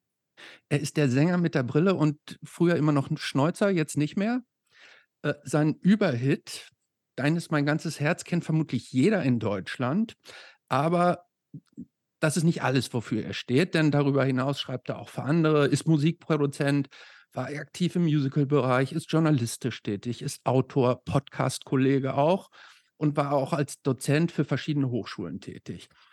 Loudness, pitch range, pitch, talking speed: -26 LUFS, 135-160 Hz, 145 Hz, 155 wpm